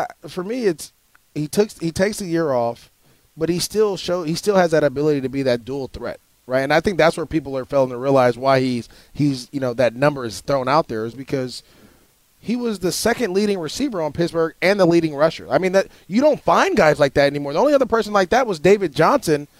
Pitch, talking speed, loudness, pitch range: 160 Hz, 240 wpm, -19 LUFS, 135-190 Hz